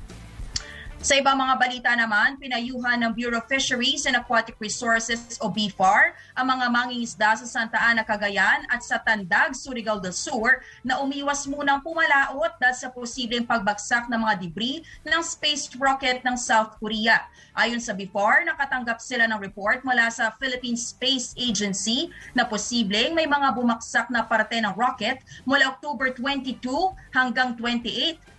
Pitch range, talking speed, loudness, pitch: 225-265 Hz, 150 wpm, -23 LUFS, 245 Hz